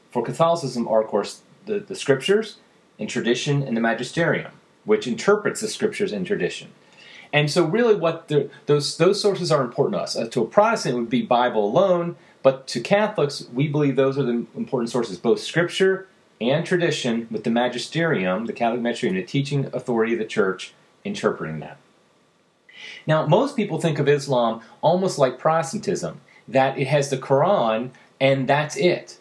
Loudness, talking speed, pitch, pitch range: -22 LUFS, 175 wpm, 145 Hz, 125-190 Hz